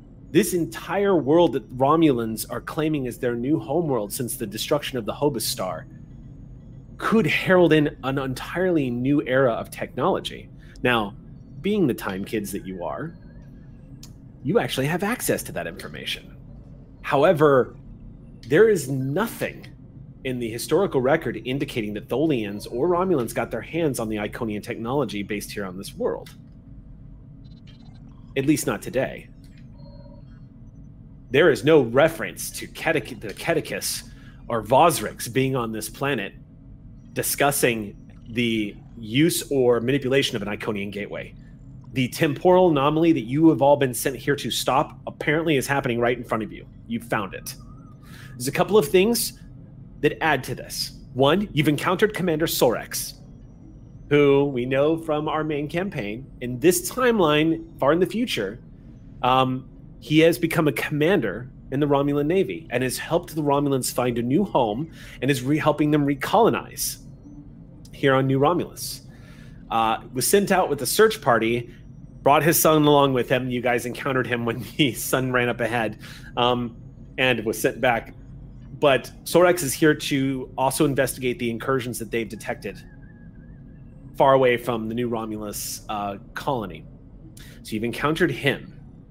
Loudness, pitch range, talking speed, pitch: -23 LUFS, 120-150 Hz, 155 wpm, 135 Hz